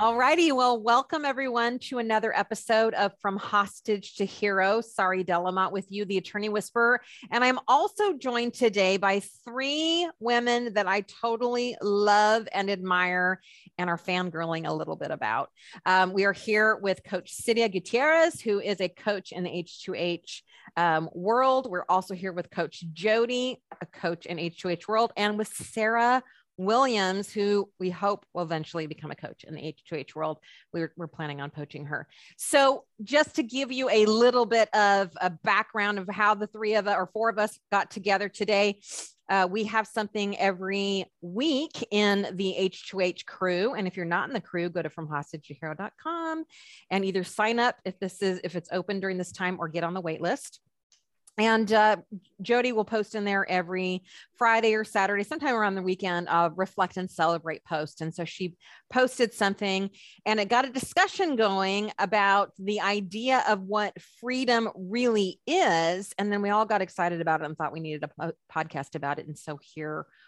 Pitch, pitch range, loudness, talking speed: 200 Hz, 180-225 Hz, -27 LUFS, 180 wpm